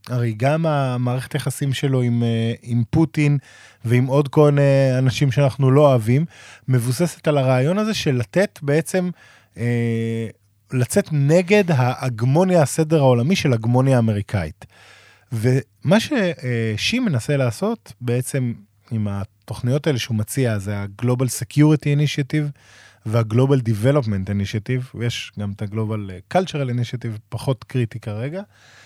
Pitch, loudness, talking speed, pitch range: 130 Hz, -20 LUFS, 125 wpm, 115-145 Hz